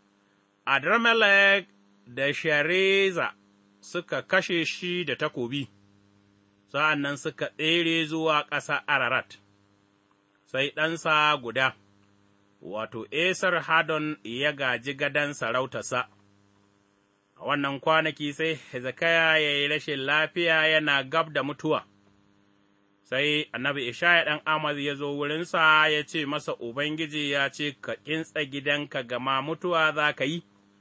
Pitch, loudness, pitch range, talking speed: 145 Hz, -25 LUFS, 100-155 Hz, 110 wpm